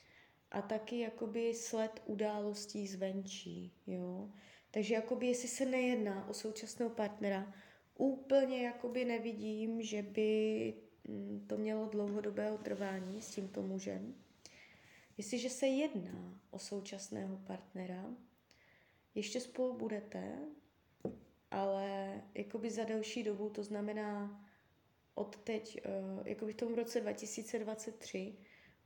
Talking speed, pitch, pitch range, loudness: 105 wpm, 215 Hz, 195-230 Hz, -41 LUFS